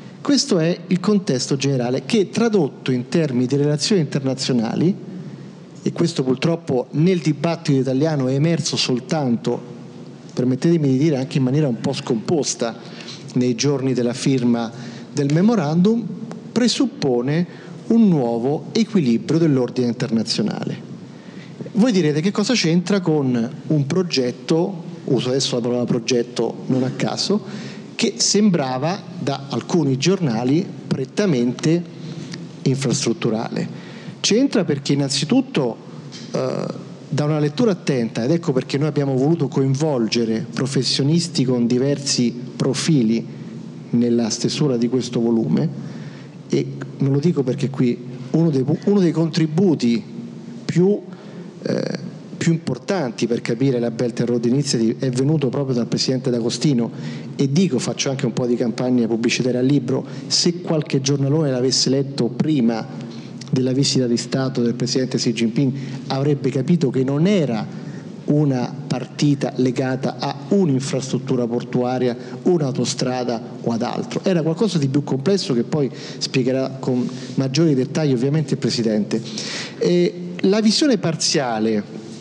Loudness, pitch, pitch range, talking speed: -20 LUFS, 140 Hz, 125-170 Hz, 125 wpm